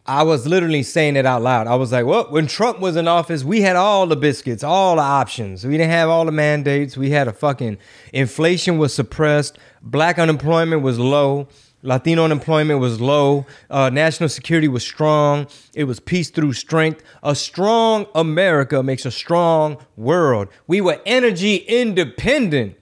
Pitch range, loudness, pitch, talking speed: 140-165 Hz, -17 LUFS, 150 Hz, 175 wpm